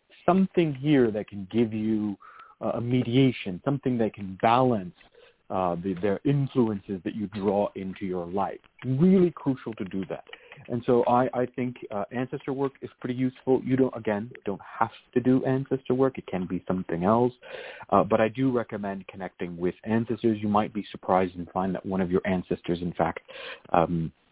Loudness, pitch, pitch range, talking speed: -27 LUFS, 110 Hz, 95-130 Hz, 185 wpm